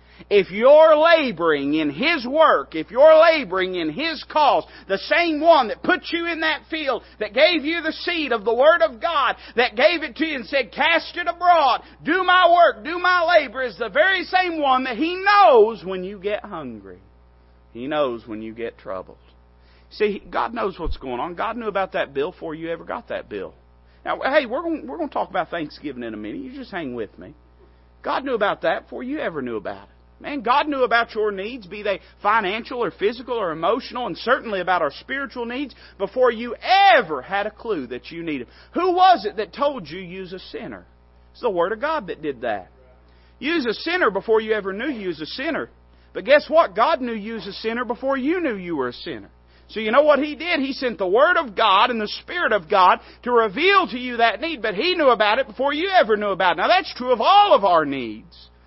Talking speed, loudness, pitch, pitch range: 230 wpm, -20 LUFS, 250 Hz, 190-320 Hz